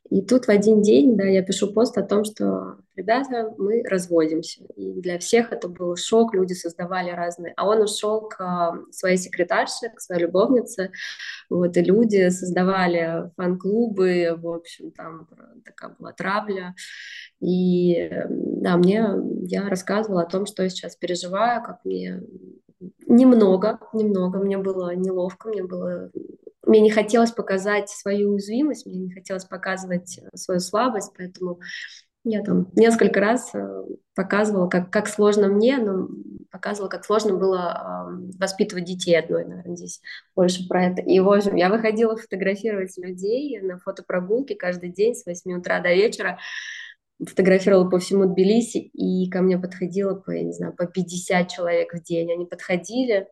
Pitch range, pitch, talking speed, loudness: 180-210 Hz, 190 Hz, 150 wpm, -22 LUFS